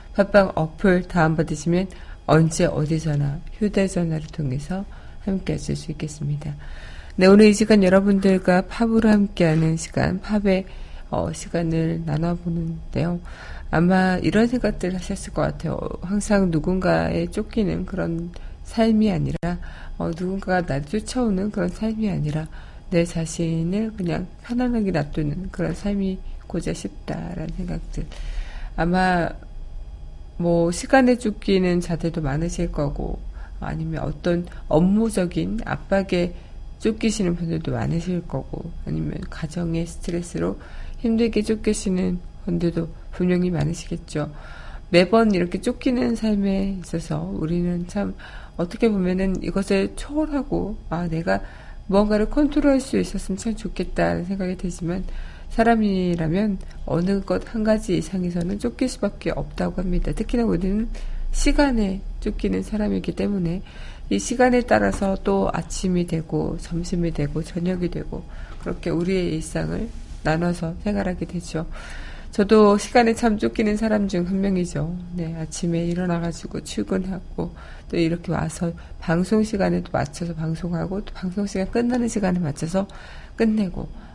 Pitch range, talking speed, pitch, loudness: 165-200 Hz, 300 characters per minute, 180 Hz, -23 LUFS